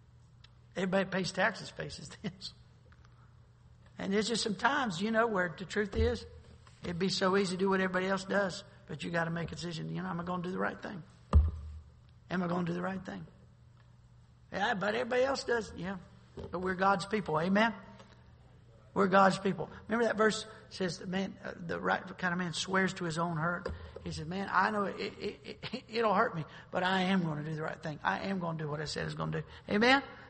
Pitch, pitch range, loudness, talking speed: 185 Hz, 170-200 Hz, -33 LUFS, 230 wpm